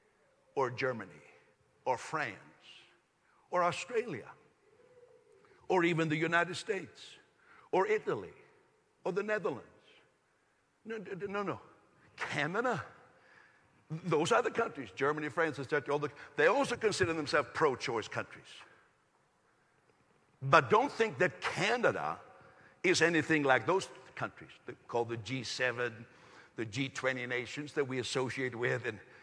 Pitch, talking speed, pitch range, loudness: 160 Hz, 120 wpm, 130-205 Hz, -33 LUFS